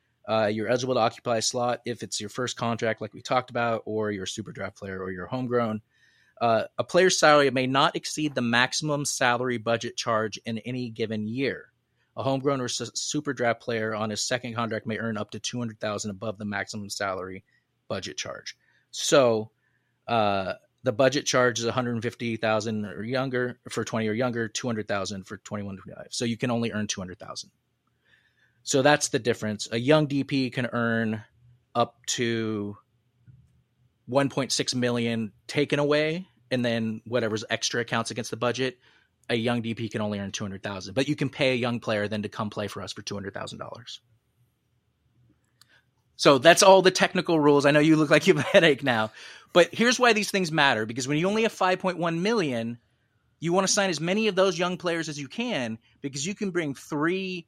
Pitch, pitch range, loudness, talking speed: 120 Hz, 110-140 Hz, -25 LUFS, 185 wpm